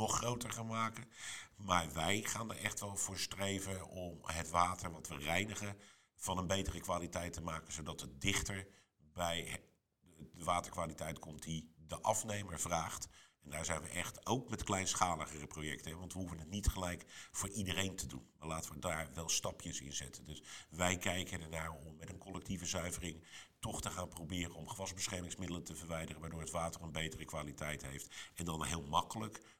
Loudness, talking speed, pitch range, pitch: -41 LUFS, 180 wpm, 80-95 Hz, 90 Hz